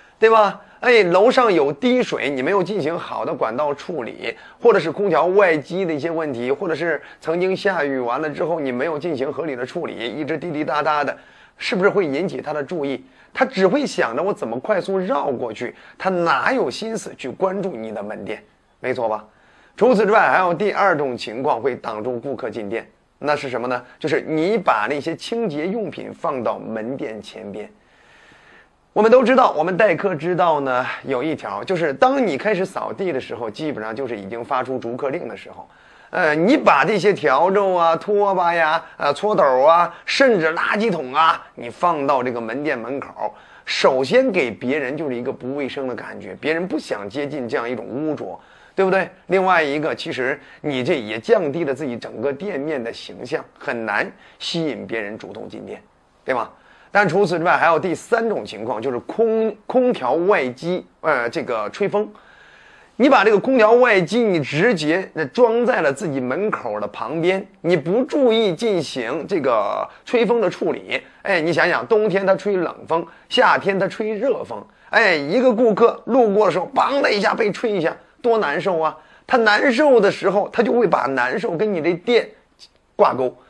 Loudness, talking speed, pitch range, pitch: -19 LUFS, 275 characters per minute, 160-225 Hz, 190 Hz